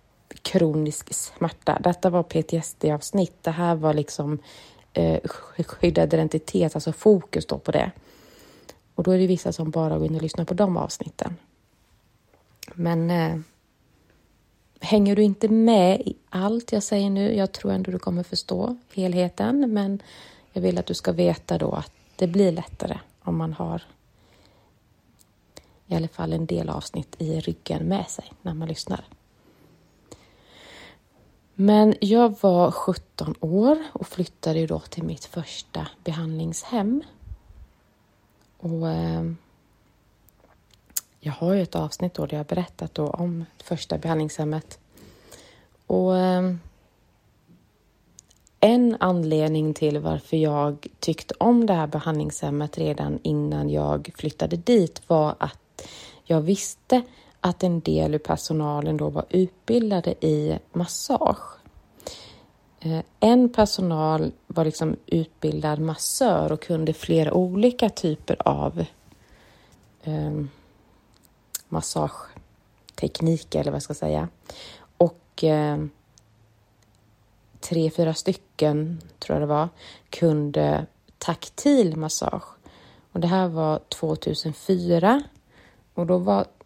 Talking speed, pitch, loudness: 120 wpm, 160 Hz, -24 LUFS